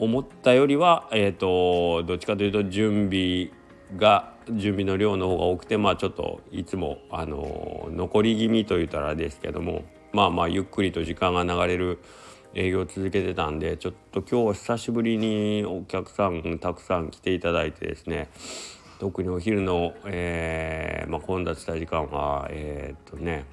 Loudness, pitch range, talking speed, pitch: -26 LUFS, 85-105 Hz, 330 characters per minute, 90 Hz